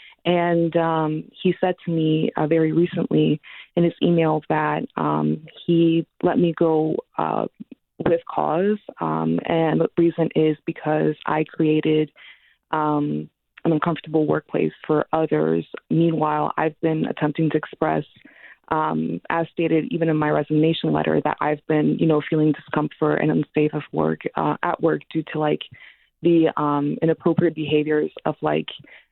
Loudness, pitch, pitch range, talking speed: -22 LUFS, 155 Hz, 150-165 Hz, 150 wpm